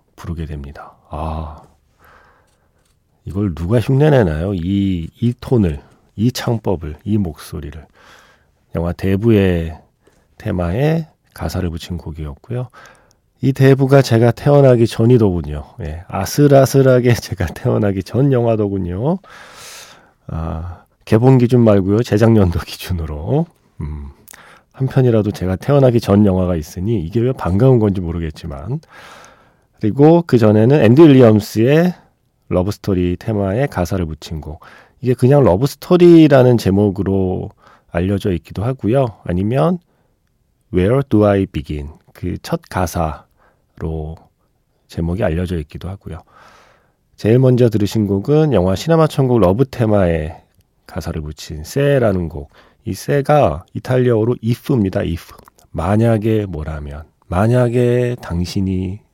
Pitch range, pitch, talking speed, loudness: 85-125 Hz, 105 Hz, 275 characters per minute, -15 LUFS